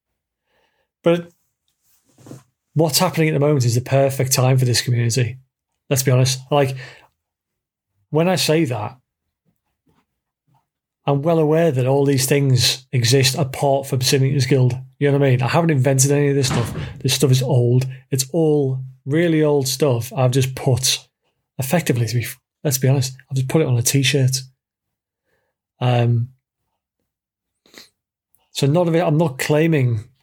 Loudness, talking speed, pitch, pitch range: -18 LUFS, 155 wpm, 135 Hz, 130-150 Hz